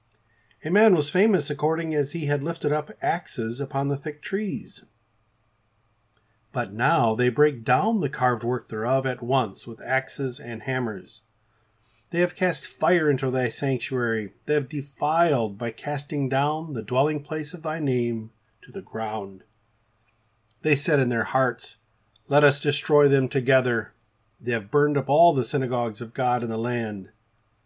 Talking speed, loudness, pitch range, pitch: 160 wpm, -24 LUFS, 110-145 Hz, 125 Hz